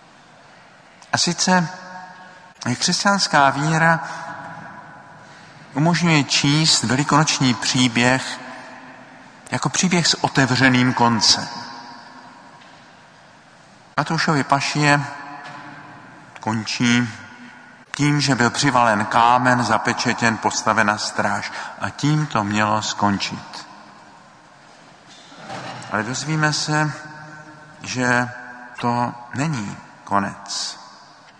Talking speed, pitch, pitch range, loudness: 70 wpm, 140 Hz, 120-155 Hz, -19 LUFS